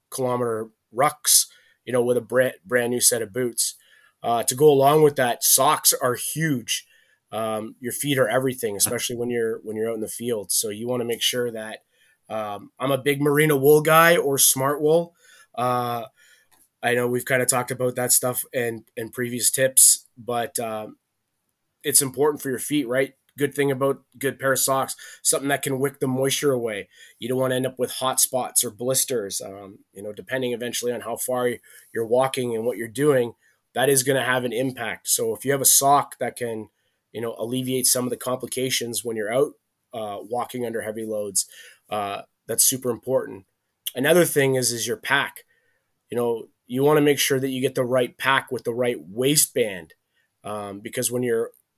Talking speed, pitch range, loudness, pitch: 200 wpm, 120-135 Hz, -22 LUFS, 125 Hz